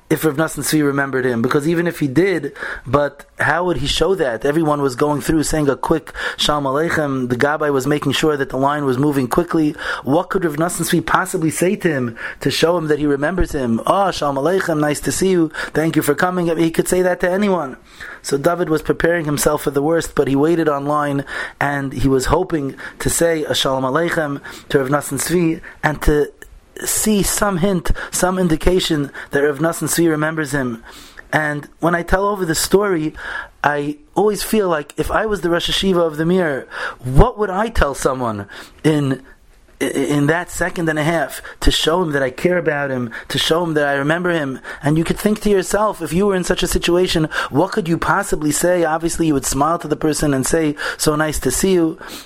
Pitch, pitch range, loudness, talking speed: 160 Hz, 145-175 Hz, -18 LUFS, 210 wpm